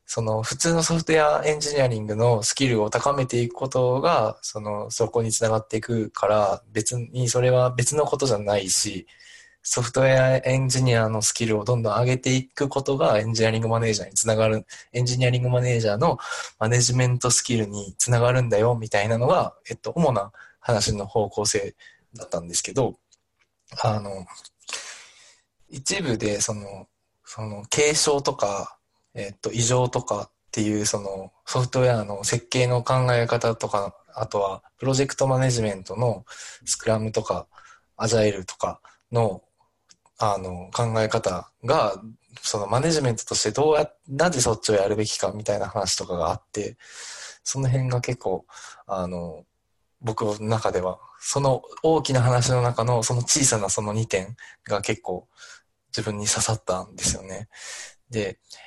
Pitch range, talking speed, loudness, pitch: 105-125 Hz, 330 characters per minute, -23 LUFS, 115 Hz